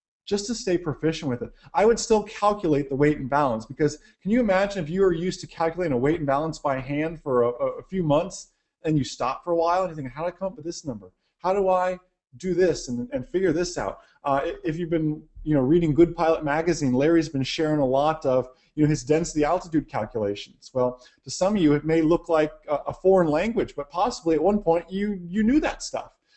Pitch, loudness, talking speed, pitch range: 160 Hz, -24 LUFS, 245 wpm, 145-180 Hz